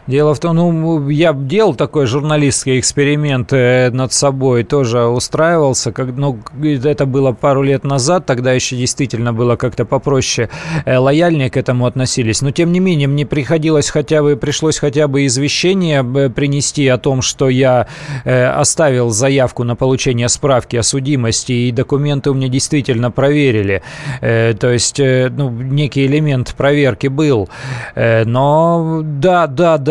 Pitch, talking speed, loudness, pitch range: 140 Hz, 140 wpm, -13 LUFS, 125-150 Hz